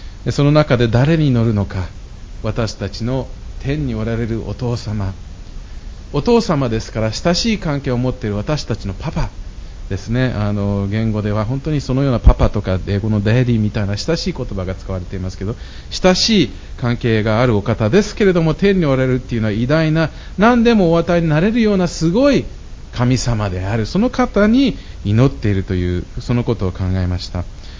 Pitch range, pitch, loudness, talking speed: 100-150 Hz, 115 Hz, -17 LUFS, 360 characters per minute